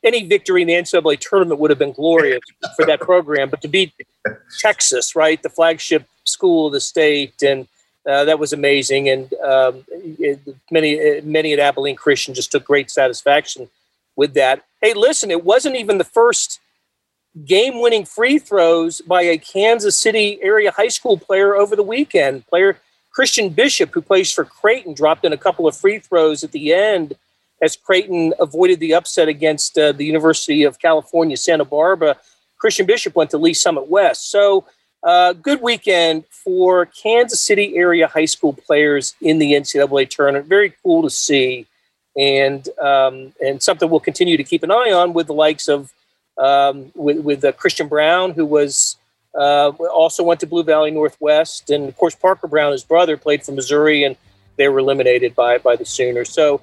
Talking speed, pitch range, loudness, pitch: 180 wpm, 145-195 Hz, -15 LUFS, 160 Hz